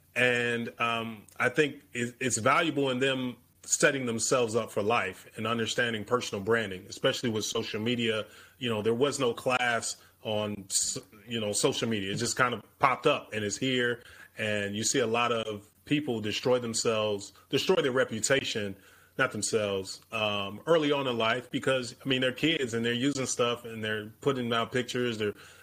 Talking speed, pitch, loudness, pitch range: 175 wpm, 115 Hz, -29 LUFS, 105-125 Hz